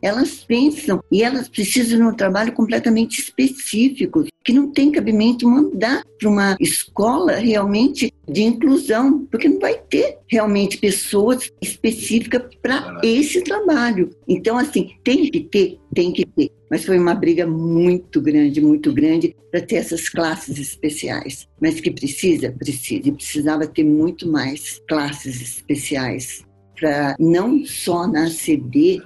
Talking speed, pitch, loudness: 140 wpm, 220 Hz, -18 LUFS